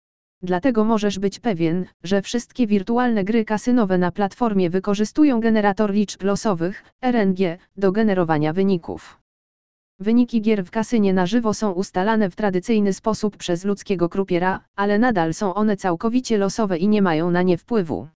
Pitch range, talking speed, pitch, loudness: 185-225 Hz, 150 wpm, 205 Hz, -21 LUFS